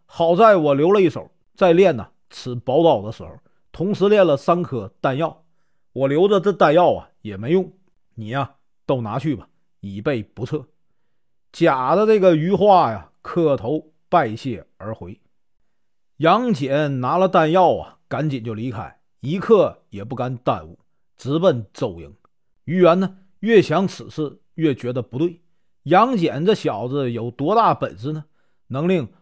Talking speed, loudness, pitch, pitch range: 215 characters per minute, -19 LUFS, 145 Hz, 120-175 Hz